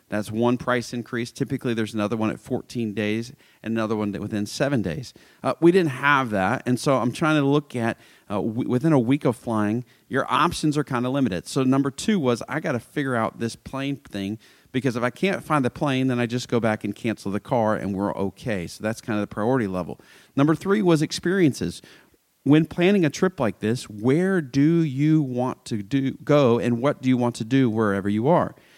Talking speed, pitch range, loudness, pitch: 220 wpm, 110-145 Hz, -23 LUFS, 125 Hz